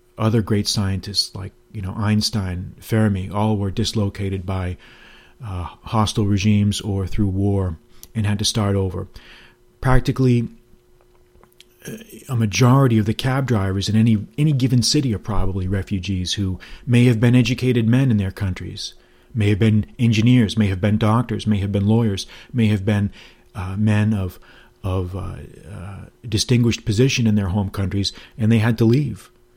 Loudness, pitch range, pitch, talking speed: -20 LUFS, 100-115 Hz, 105 Hz, 160 wpm